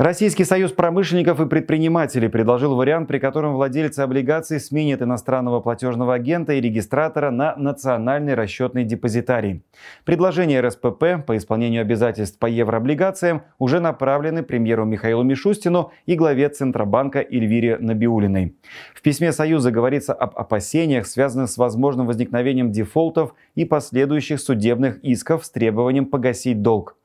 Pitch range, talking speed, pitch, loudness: 120-155 Hz, 125 wpm, 135 Hz, -20 LUFS